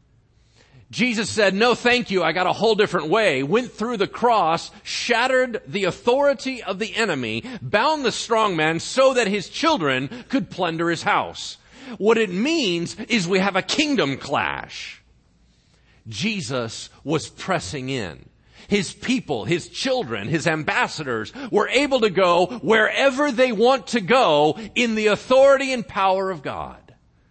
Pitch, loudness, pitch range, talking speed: 205 Hz, -21 LUFS, 165-245 Hz, 150 wpm